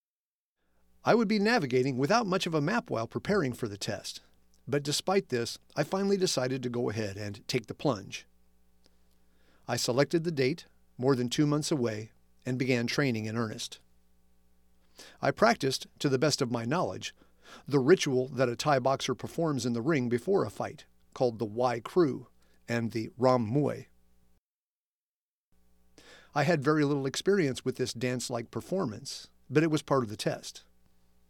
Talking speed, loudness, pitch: 165 wpm, -30 LUFS, 120 Hz